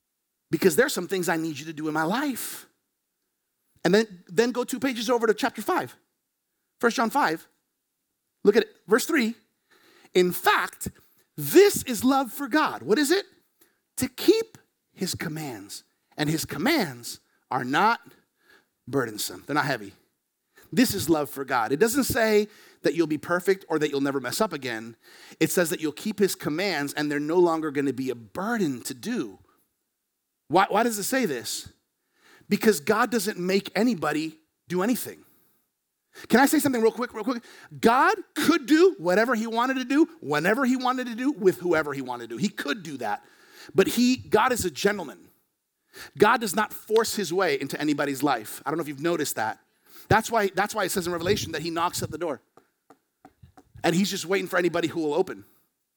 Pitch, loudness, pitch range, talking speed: 210 Hz, -25 LUFS, 165-255 Hz, 190 wpm